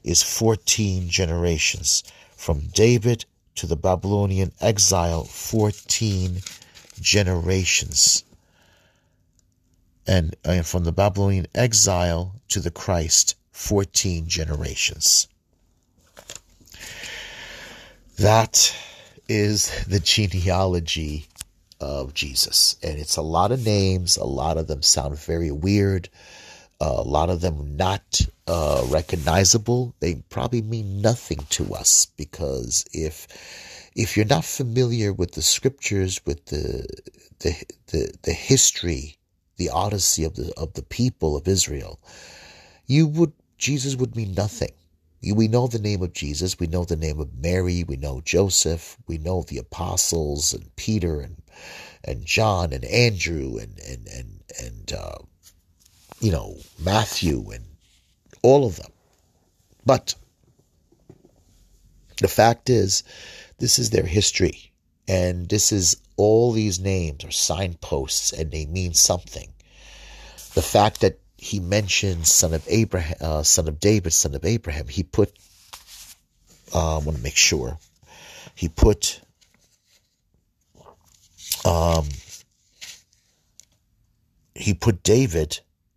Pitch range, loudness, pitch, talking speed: 80-100 Hz, -21 LUFS, 90 Hz, 120 wpm